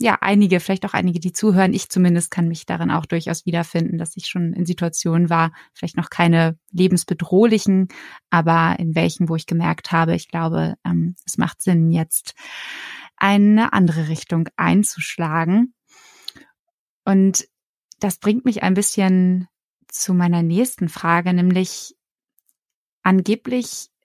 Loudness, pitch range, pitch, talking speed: -19 LUFS, 170-200 Hz, 180 Hz, 135 wpm